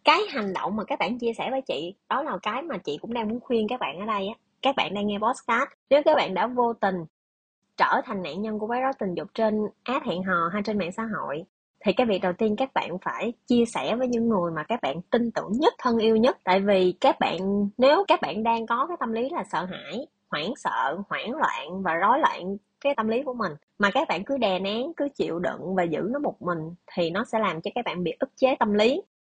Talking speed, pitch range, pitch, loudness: 260 wpm, 195-255 Hz, 225 Hz, -26 LUFS